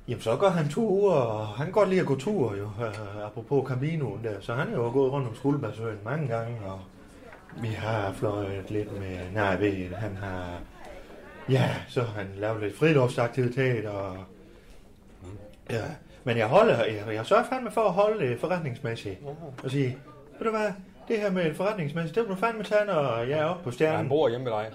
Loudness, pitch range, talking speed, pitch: -28 LUFS, 105-155 Hz, 205 wpm, 125 Hz